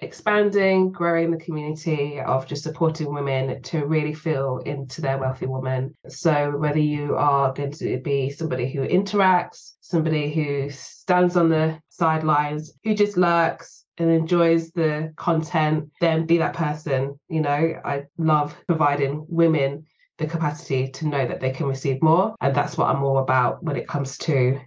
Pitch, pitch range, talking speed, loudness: 150 Hz, 140-165 Hz, 165 wpm, -23 LUFS